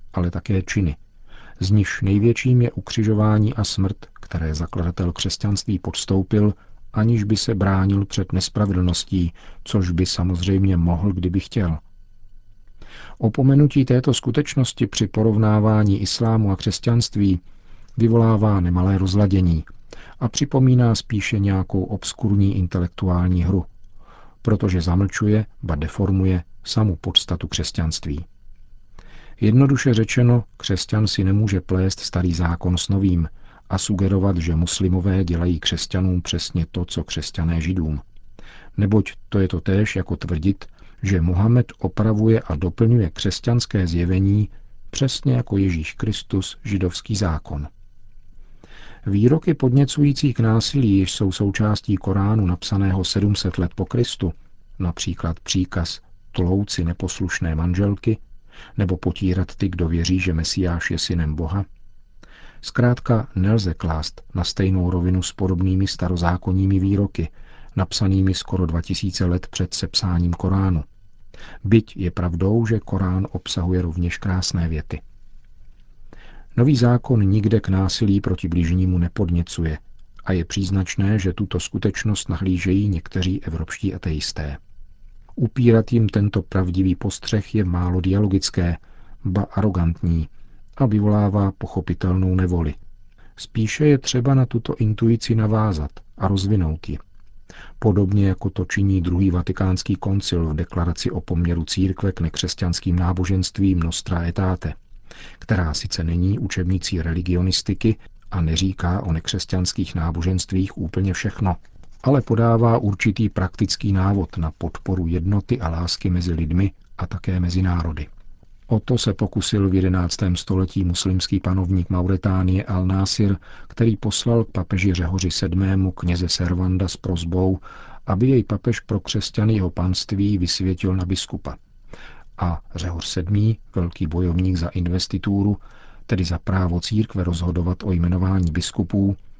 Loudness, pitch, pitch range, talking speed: -21 LUFS, 95 Hz, 90-105 Hz, 120 wpm